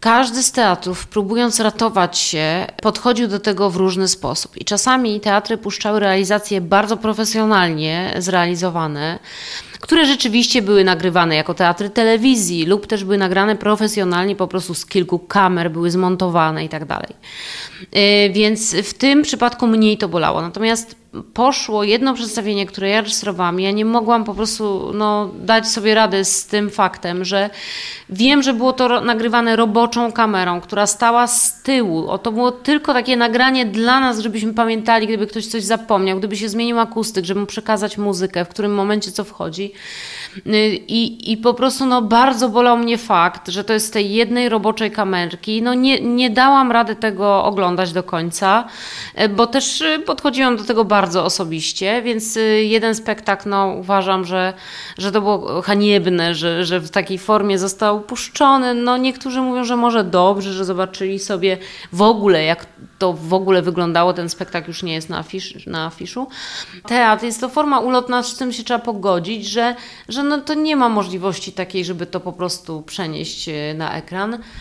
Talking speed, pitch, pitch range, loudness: 165 wpm, 210 Hz, 190-235 Hz, -17 LUFS